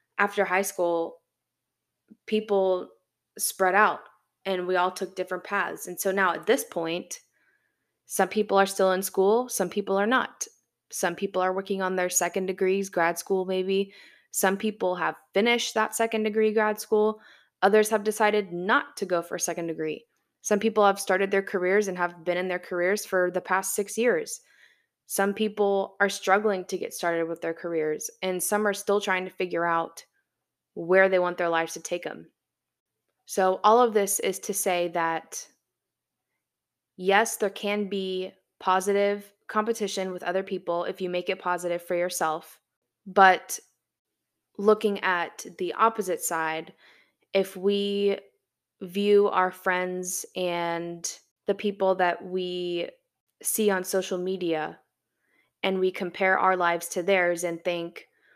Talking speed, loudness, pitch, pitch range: 160 wpm, -26 LUFS, 190 Hz, 180-205 Hz